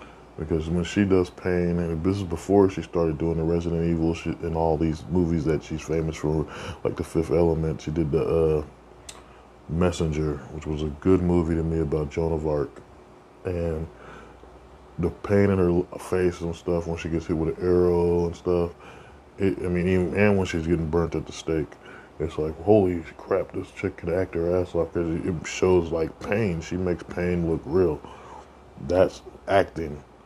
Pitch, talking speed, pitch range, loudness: 85 Hz, 190 wpm, 80-90 Hz, -25 LUFS